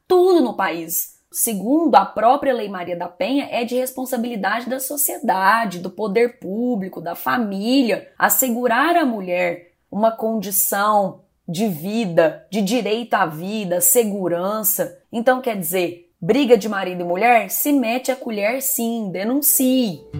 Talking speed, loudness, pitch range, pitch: 135 wpm, -19 LUFS, 185-255 Hz, 225 Hz